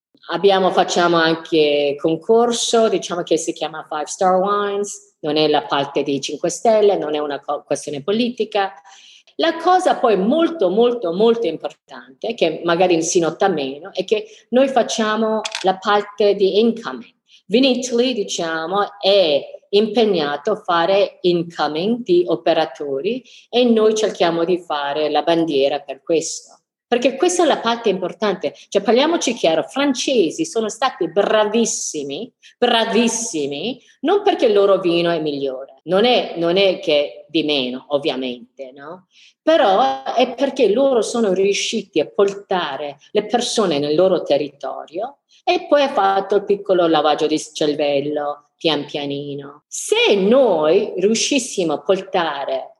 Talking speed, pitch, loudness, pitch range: 140 wpm, 195 Hz, -18 LUFS, 155-230 Hz